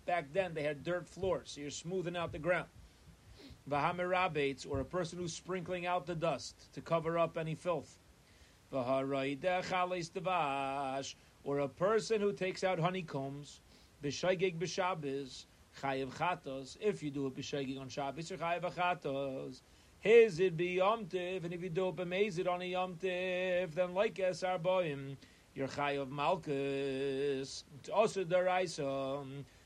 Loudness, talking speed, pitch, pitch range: -36 LUFS, 130 wpm, 165 Hz, 135-185 Hz